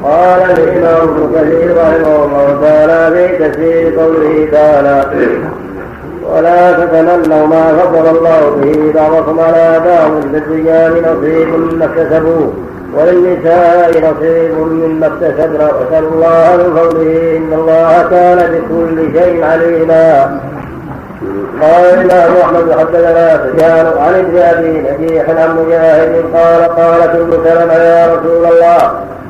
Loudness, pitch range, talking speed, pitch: -8 LUFS, 160-170 Hz, 110 wpm, 165 Hz